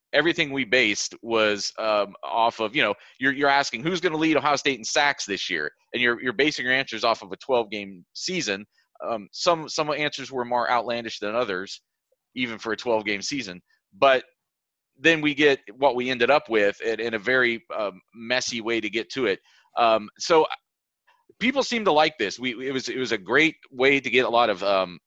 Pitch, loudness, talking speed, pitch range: 125 Hz, -23 LUFS, 215 wpm, 110-145 Hz